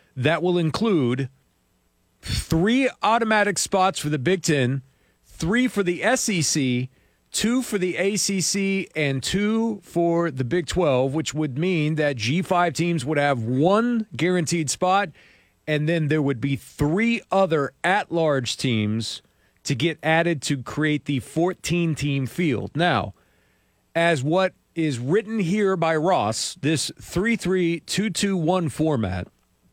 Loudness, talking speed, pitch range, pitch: -23 LUFS, 140 wpm, 140-185 Hz, 165 Hz